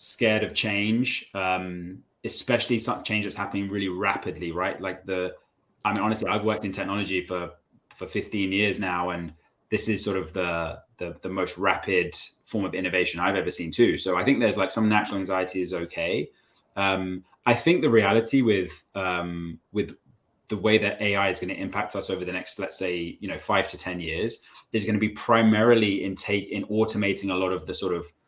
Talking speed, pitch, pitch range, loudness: 205 wpm, 100 Hz, 90-110 Hz, -26 LUFS